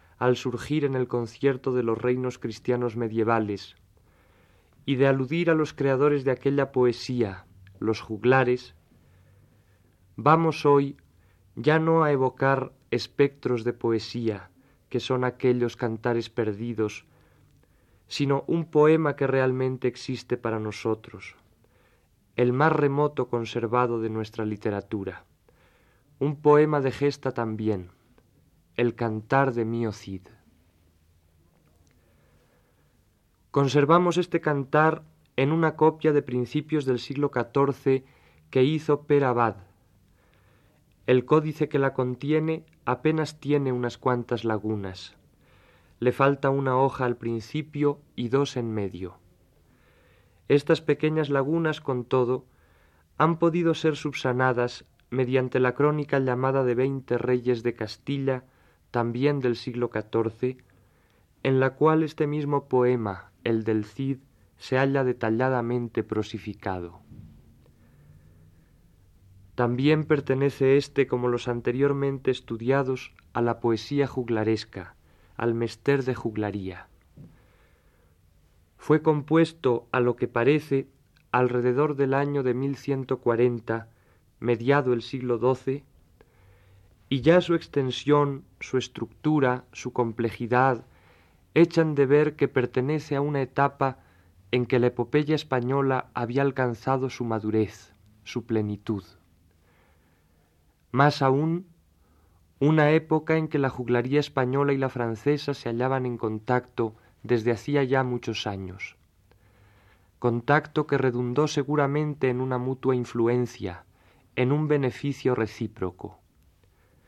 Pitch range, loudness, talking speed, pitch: 105-140 Hz, -25 LUFS, 110 wpm, 125 Hz